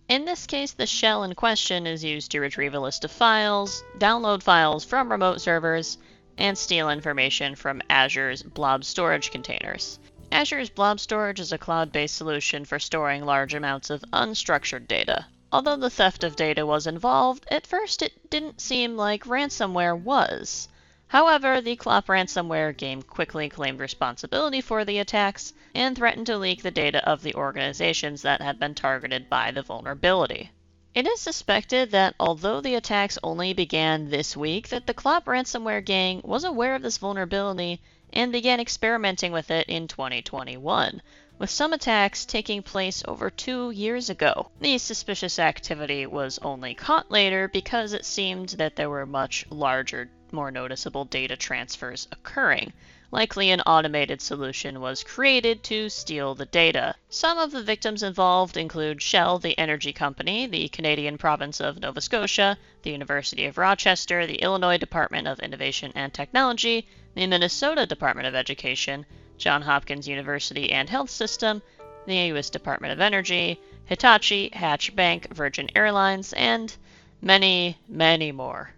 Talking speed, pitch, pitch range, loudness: 155 wpm, 180 Hz, 145-215 Hz, -24 LUFS